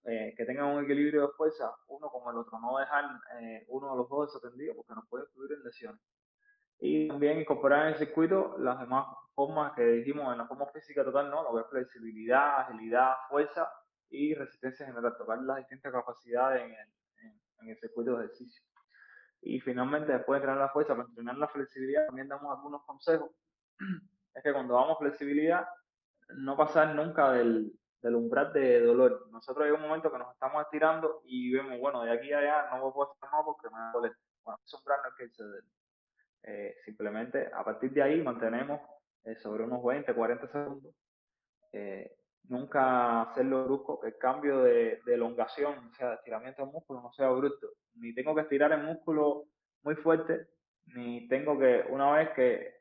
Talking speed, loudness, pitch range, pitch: 185 wpm, -31 LUFS, 125-155 Hz, 145 Hz